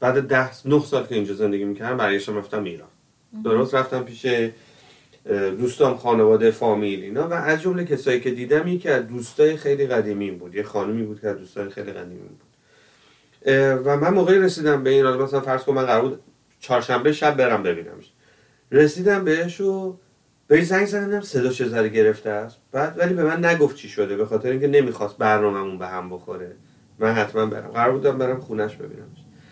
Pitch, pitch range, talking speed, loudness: 130 Hz, 110-150 Hz, 175 wpm, -21 LUFS